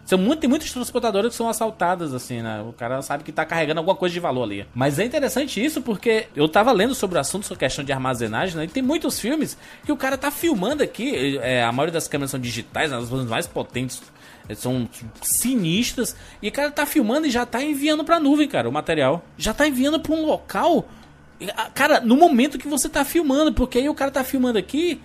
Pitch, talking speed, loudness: 230 Hz, 230 wpm, -22 LUFS